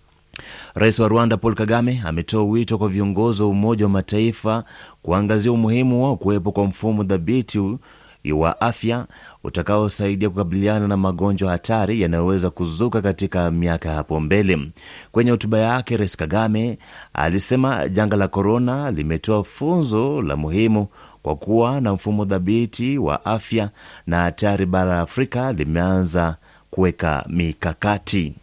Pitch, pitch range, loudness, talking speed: 105 Hz, 90-115 Hz, -20 LUFS, 130 wpm